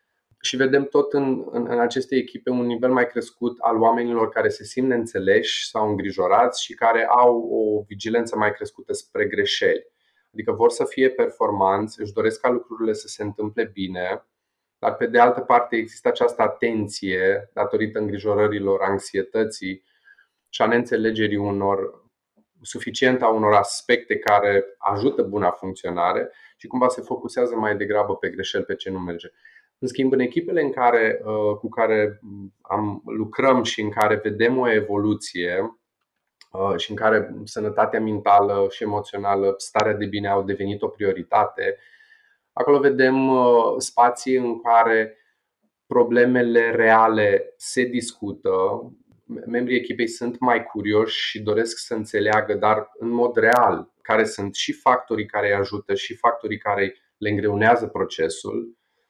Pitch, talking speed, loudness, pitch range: 115 Hz, 145 wpm, -21 LUFS, 105-130 Hz